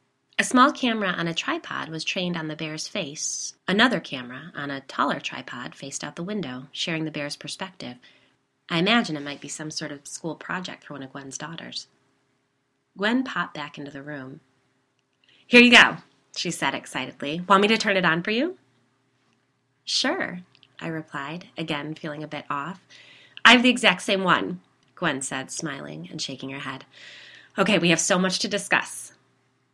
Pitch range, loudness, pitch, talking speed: 140-195 Hz, -23 LUFS, 160 Hz, 180 wpm